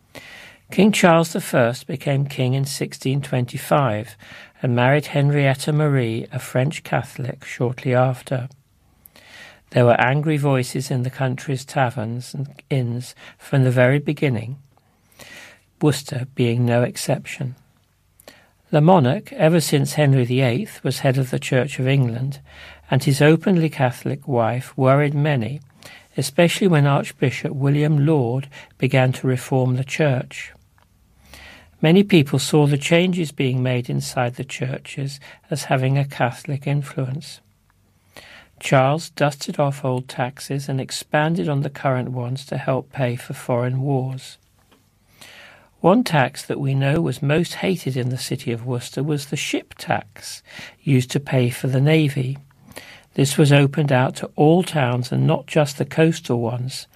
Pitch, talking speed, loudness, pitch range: 135 Hz, 140 wpm, -20 LUFS, 125-150 Hz